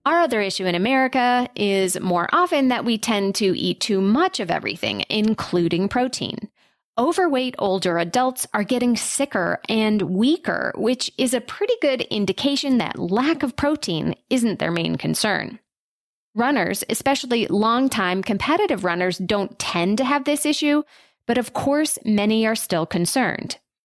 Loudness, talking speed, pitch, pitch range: -21 LUFS, 150 wpm, 230 Hz, 195-275 Hz